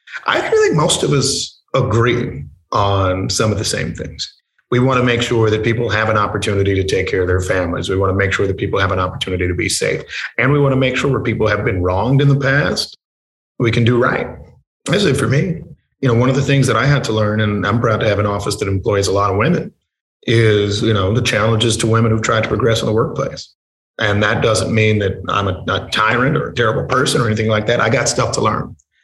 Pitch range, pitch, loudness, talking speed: 100-125 Hz, 110 Hz, -16 LUFS, 255 wpm